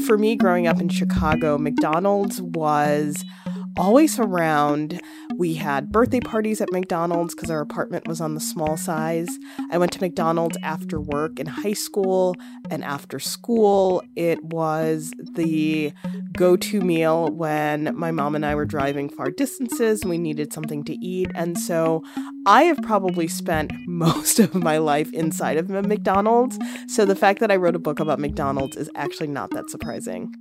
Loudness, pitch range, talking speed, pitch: -22 LUFS, 155-210 Hz, 170 wpm, 180 Hz